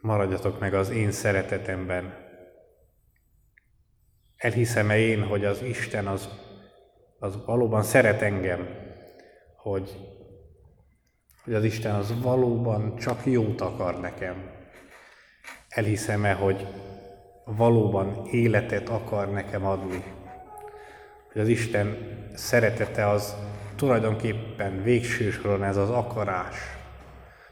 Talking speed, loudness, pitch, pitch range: 90 wpm, -26 LUFS, 105 Hz, 95-115 Hz